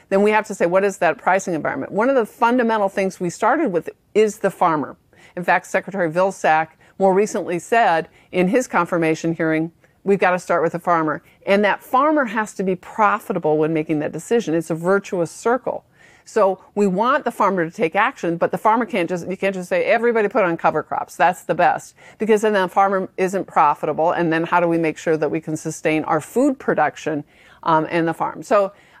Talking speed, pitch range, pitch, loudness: 215 wpm, 165-210 Hz, 185 Hz, -19 LUFS